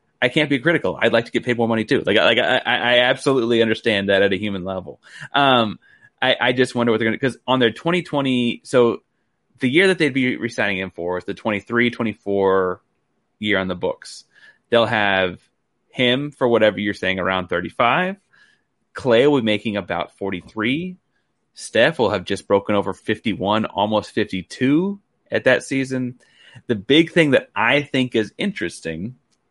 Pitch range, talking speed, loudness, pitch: 100-130 Hz, 175 wpm, -19 LUFS, 115 Hz